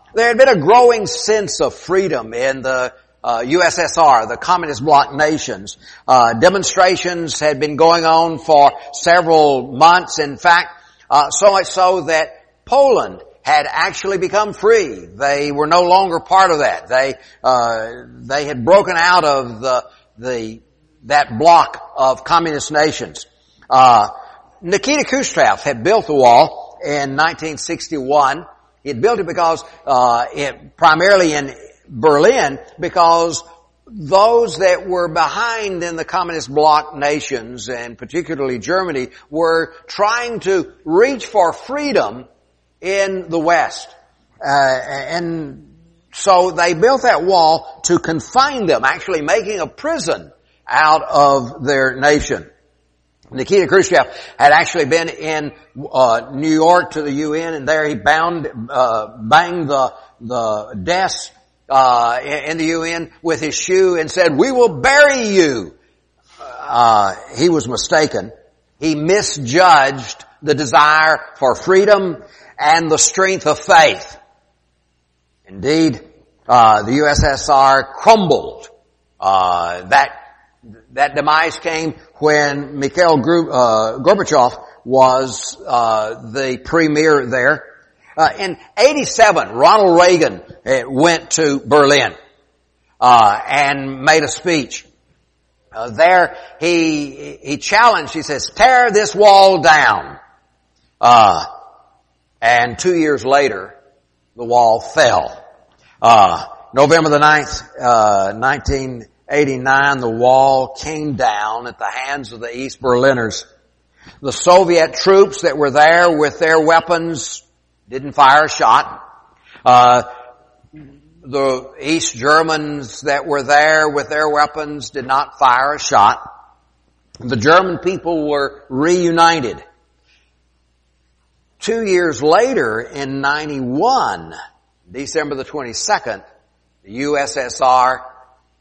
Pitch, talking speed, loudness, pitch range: 155 Hz, 120 wpm, -14 LUFS, 130-175 Hz